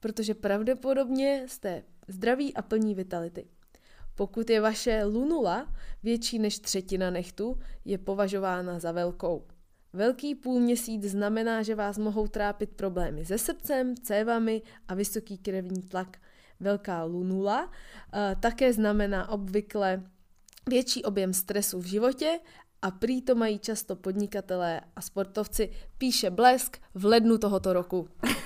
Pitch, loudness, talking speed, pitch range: 205 Hz, -29 LUFS, 125 wpm, 190-230 Hz